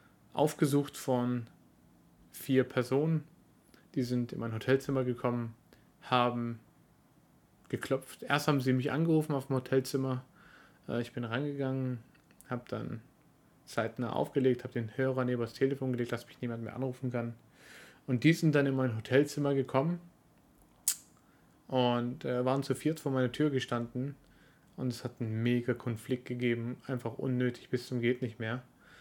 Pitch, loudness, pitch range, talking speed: 125 Hz, -33 LUFS, 120-135 Hz, 145 wpm